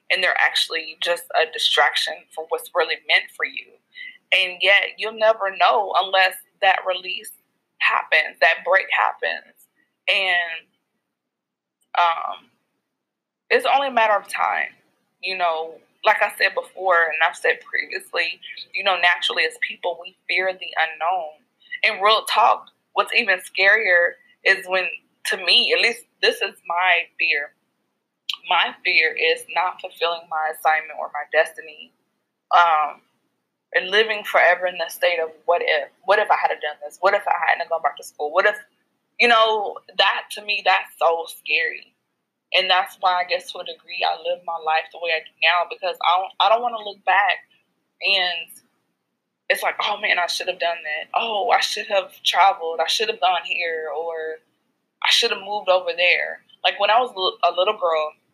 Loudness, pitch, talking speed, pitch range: -20 LUFS, 185 Hz, 175 wpm, 165-220 Hz